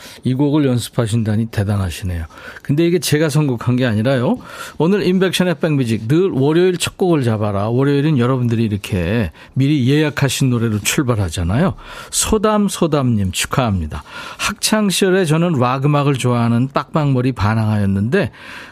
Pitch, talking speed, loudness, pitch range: 130 Hz, 355 characters per minute, -16 LUFS, 110-160 Hz